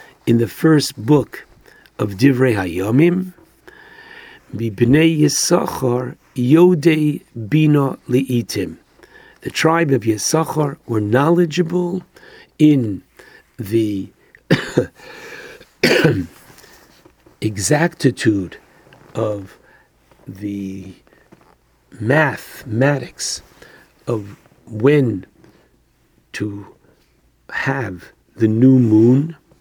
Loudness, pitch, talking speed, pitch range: -17 LUFS, 130 Hz, 65 wpm, 110-155 Hz